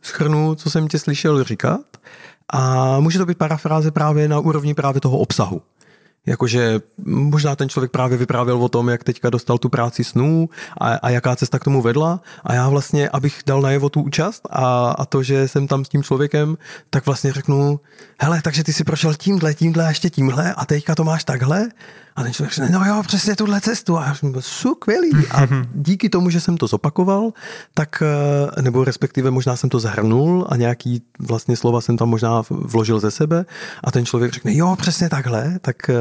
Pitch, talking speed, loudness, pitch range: 145 Hz, 200 wpm, -18 LUFS, 130-165 Hz